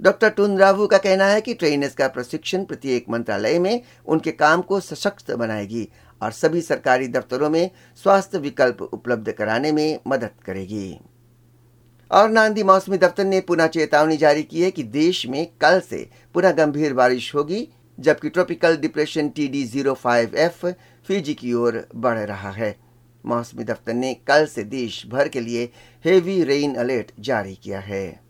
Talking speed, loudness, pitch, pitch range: 155 wpm, -20 LUFS, 150 Hz, 120-180 Hz